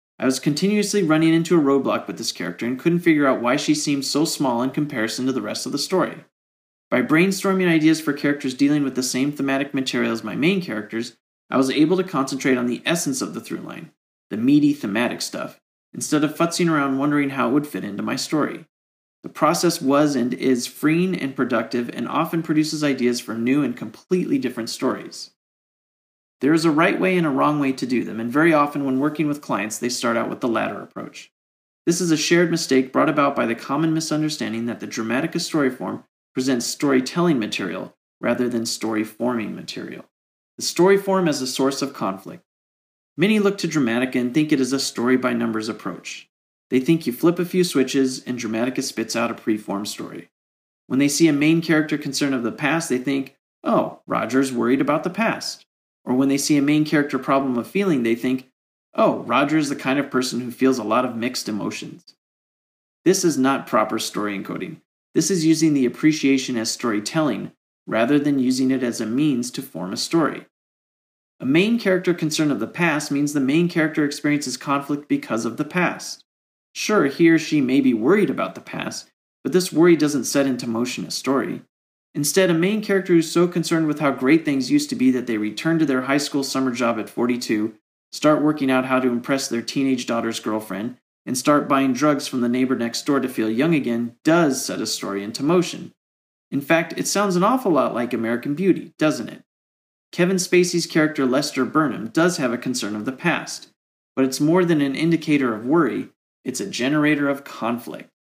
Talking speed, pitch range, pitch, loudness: 205 wpm, 120-160 Hz, 140 Hz, -21 LUFS